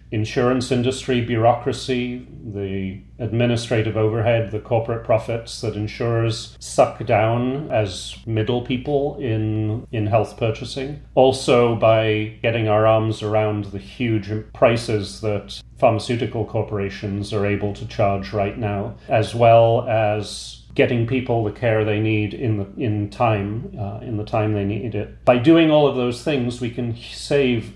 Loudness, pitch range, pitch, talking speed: -20 LUFS, 105-120 Hz, 110 Hz, 145 wpm